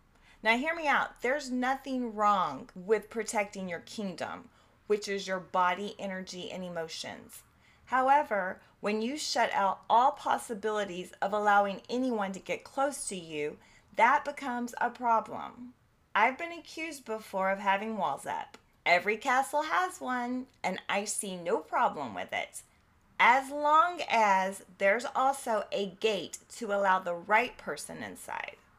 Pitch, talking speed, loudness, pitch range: 215 Hz, 145 wpm, -30 LUFS, 195-255 Hz